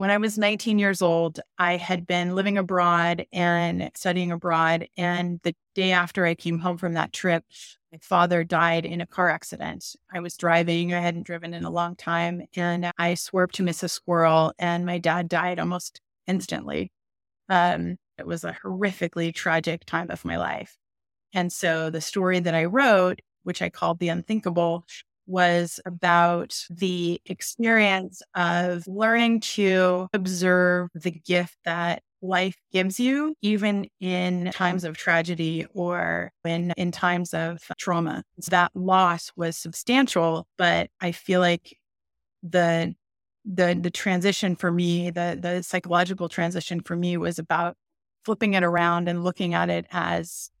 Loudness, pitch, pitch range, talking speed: -24 LUFS, 175 Hz, 170-185 Hz, 155 wpm